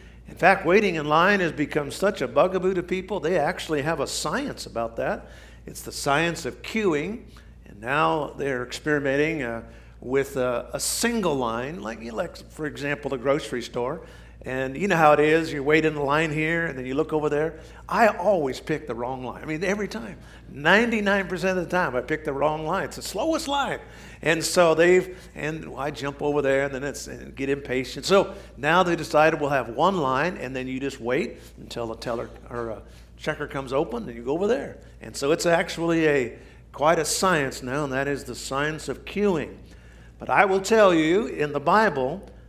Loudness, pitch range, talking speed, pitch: -24 LUFS, 130-170 Hz, 200 wpm, 150 Hz